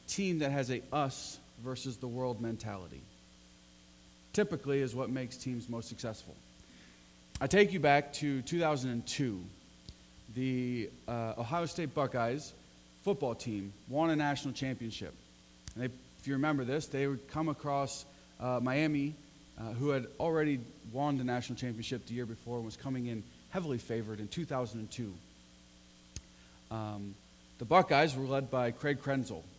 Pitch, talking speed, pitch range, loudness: 125 Hz, 145 wpm, 105-140 Hz, -35 LUFS